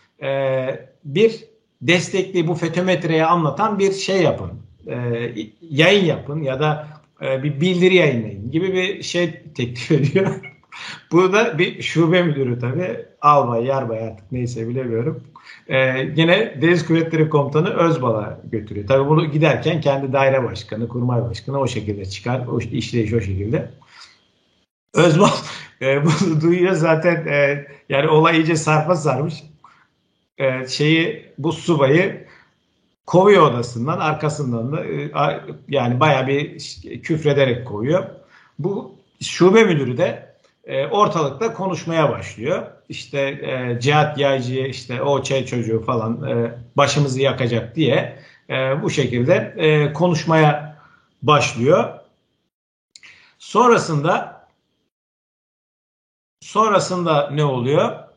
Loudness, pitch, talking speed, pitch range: -18 LUFS, 145 Hz, 115 wpm, 125-165 Hz